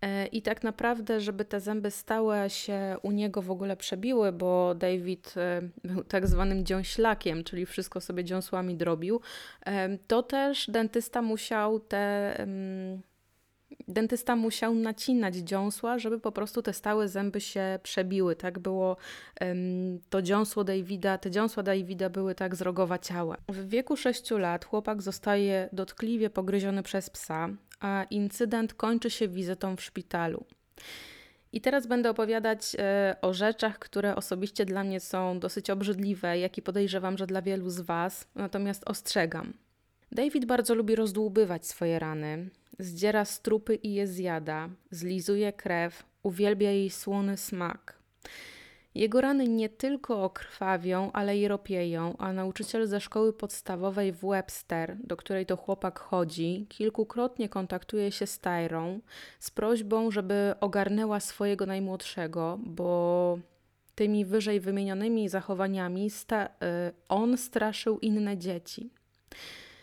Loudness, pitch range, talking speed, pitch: -31 LUFS, 185-220 Hz, 130 wpm, 200 Hz